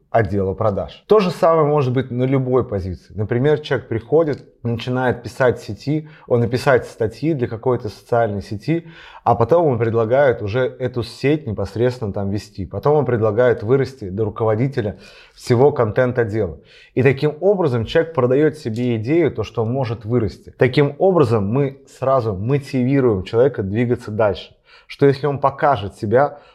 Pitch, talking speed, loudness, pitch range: 125 Hz, 155 wpm, -19 LUFS, 110-140 Hz